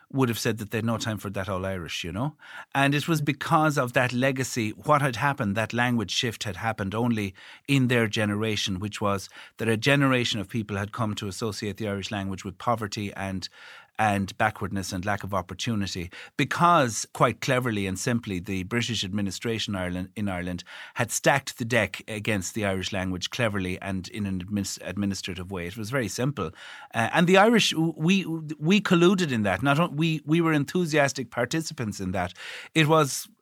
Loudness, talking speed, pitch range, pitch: -26 LUFS, 190 wpm, 100-135 Hz, 110 Hz